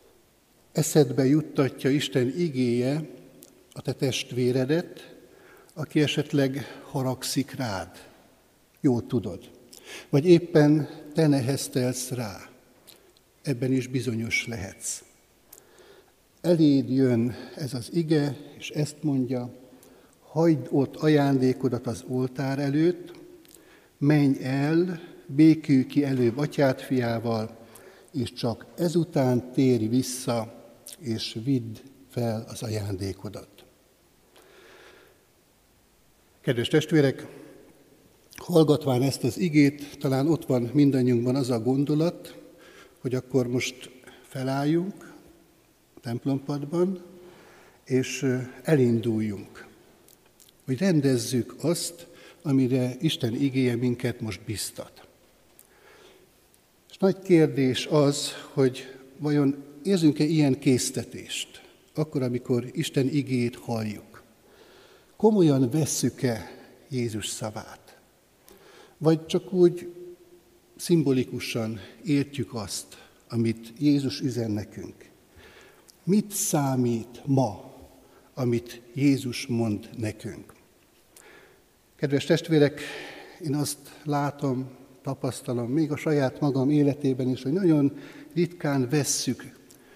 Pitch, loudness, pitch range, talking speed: 135 Hz, -26 LUFS, 125-150 Hz, 90 wpm